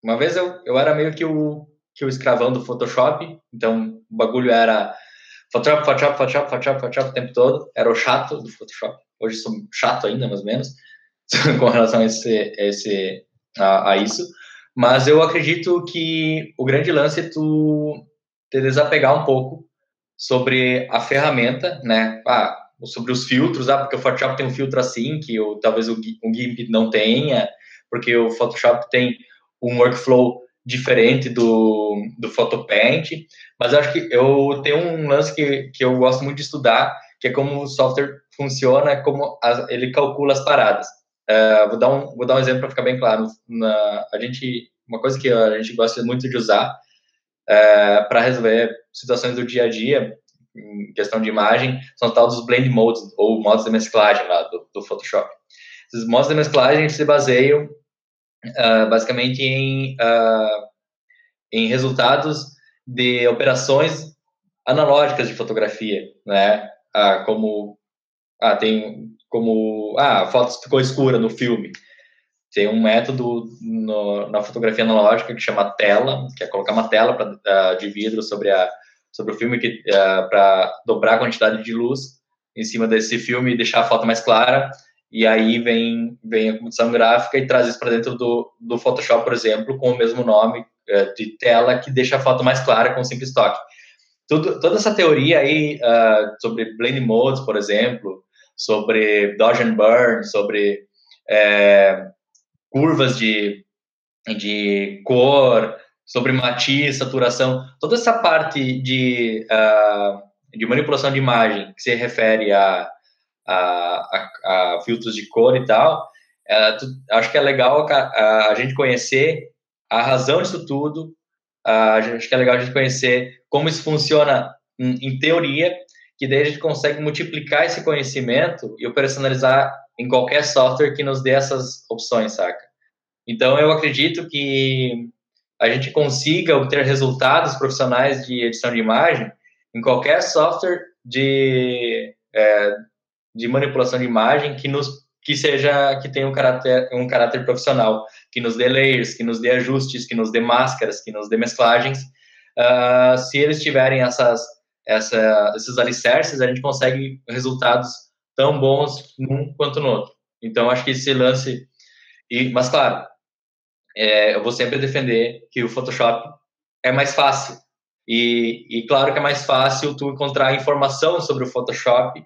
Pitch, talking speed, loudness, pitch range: 125 Hz, 165 wpm, -18 LUFS, 115-140 Hz